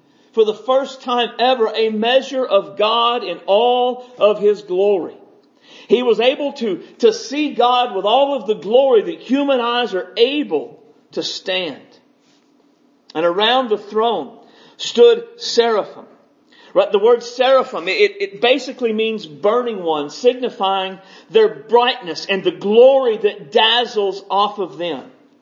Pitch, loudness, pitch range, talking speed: 240 Hz, -17 LUFS, 210-270 Hz, 140 wpm